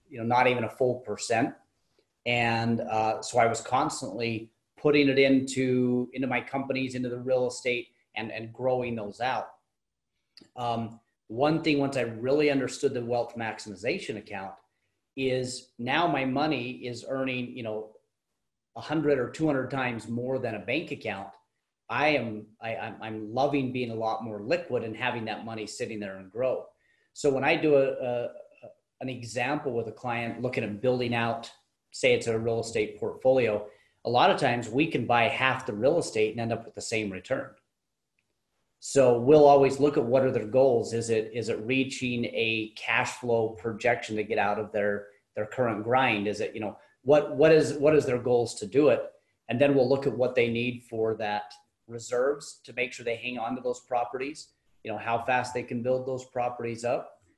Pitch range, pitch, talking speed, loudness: 115-135 Hz, 125 Hz, 195 wpm, -28 LUFS